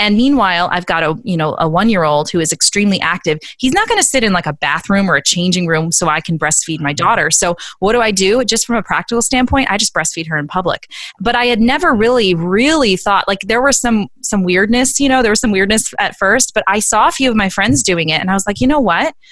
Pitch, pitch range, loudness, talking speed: 200 Hz, 170-240 Hz, -13 LUFS, 270 wpm